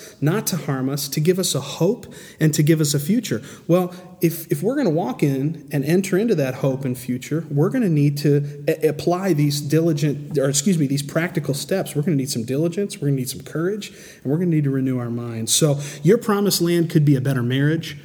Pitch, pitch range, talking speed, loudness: 155 Hz, 140-175 Hz, 250 wpm, -21 LUFS